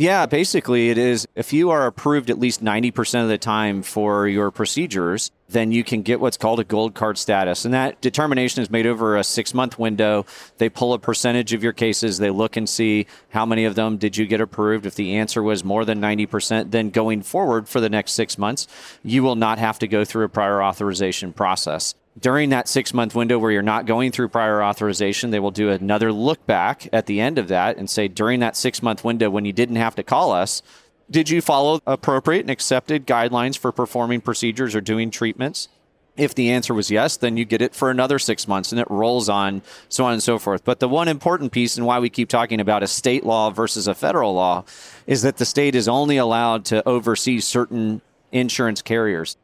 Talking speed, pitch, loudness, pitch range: 225 wpm, 115 Hz, -20 LUFS, 105-125 Hz